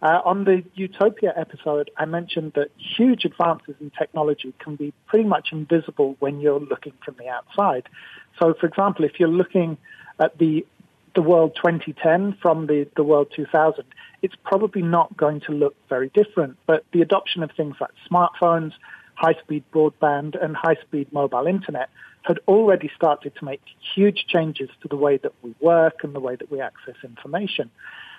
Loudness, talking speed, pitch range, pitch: -21 LUFS, 190 wpm, 150-180 Hz, 160 Hz